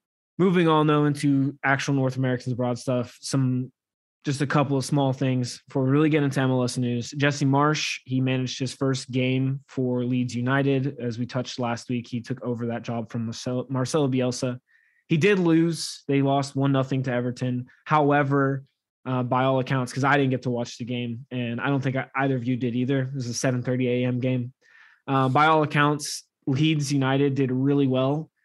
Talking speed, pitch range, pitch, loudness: 190 wpm, 125-140 Hz, 130 Hz, -24 LUFS